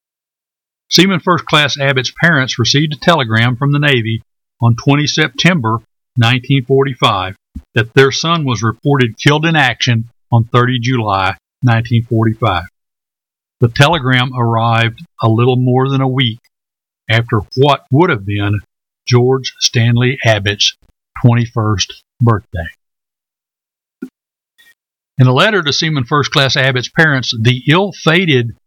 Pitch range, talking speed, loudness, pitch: 115-145 Hz, 120 wpm, -13 LUFS, 130 Hz